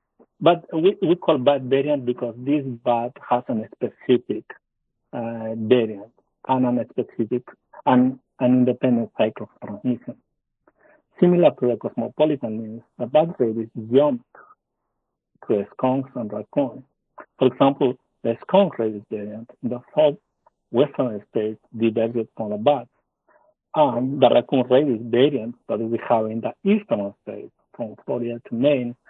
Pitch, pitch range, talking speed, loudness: 120 Hz, 115-135 Hz, 140 wpm, -22 LUFS